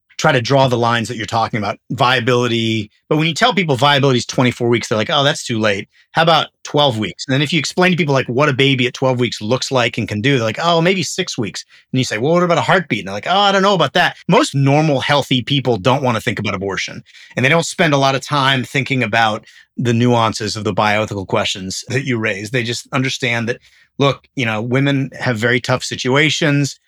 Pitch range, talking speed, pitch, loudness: 115-145 Hz, 250 wpm, 130 Hz, -16 LUFS